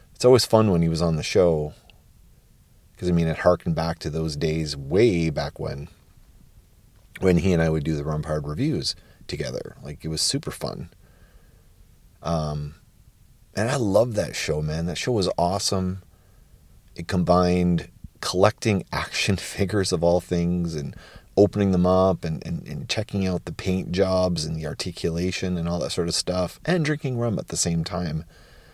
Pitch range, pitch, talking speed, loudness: 80-95 Hz, 90 Hz, 175 wpm, -24 LUFS